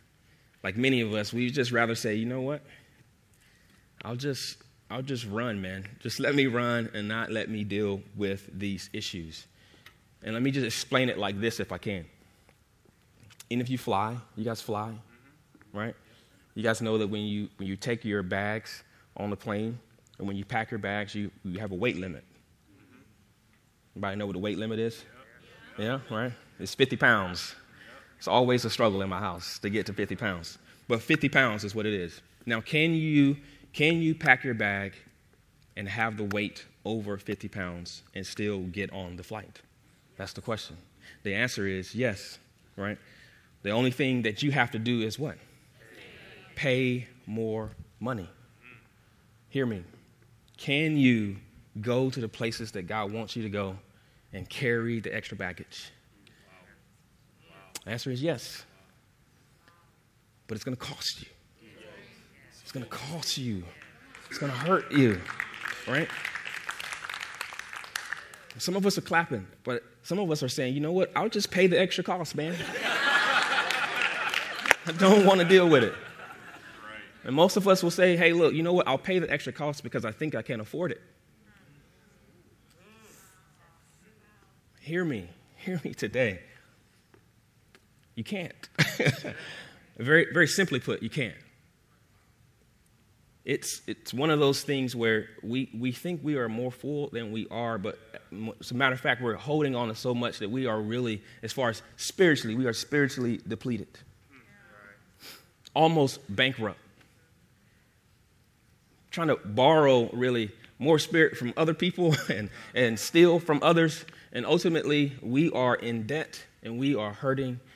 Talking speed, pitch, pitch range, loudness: 160 wpm, 120 Hz, 105-140 Hz, -28 LUFS